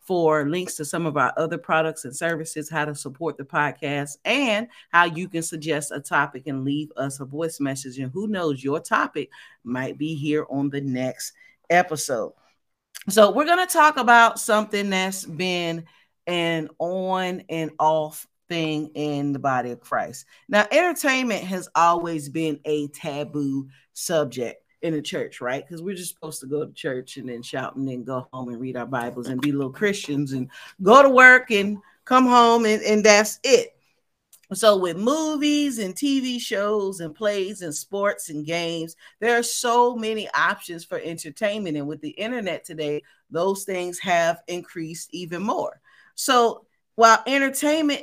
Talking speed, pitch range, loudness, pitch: 170 wpm, 150-210 Hz, -22 LUFS, 170 Hz